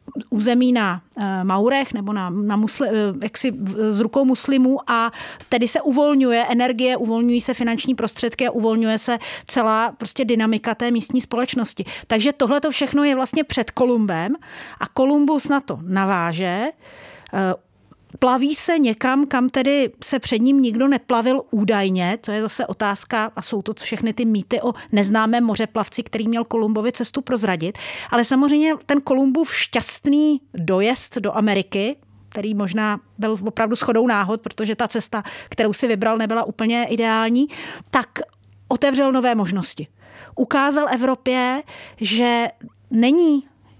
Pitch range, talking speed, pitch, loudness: 215-260 Hz, 140 wpm, 235 Hz, -20 LUFS